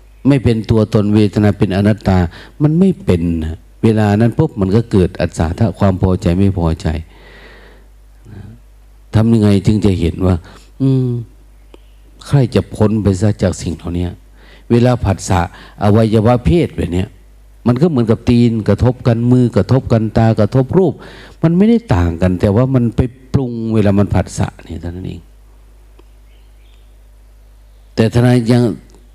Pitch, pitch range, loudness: 110 Hz, 95-120 Hz, -14 LUFS